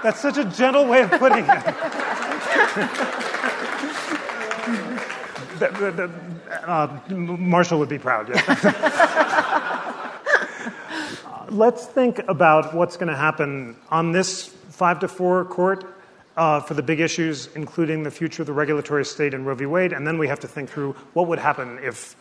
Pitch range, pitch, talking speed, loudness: 150-195 Hz, 175 Hz, 150 wpm, -21 LUFS